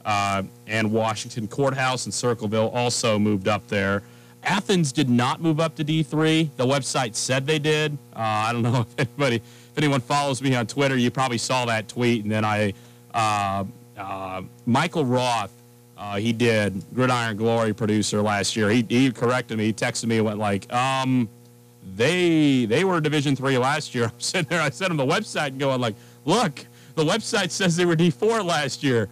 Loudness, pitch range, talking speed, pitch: -23 LUFS, 110-145 Hz, 190 wpm, 120 Hz